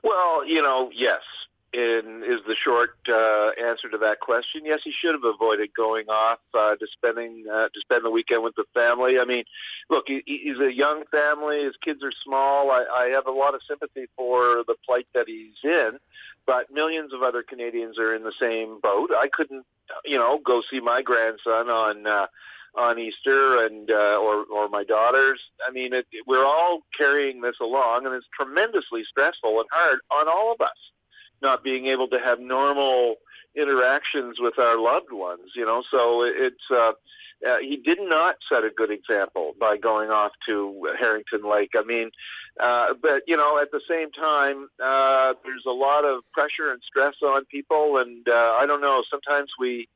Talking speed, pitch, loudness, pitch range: 195 wpm, 125 Hz, -23 LUFS, 115-145 Hz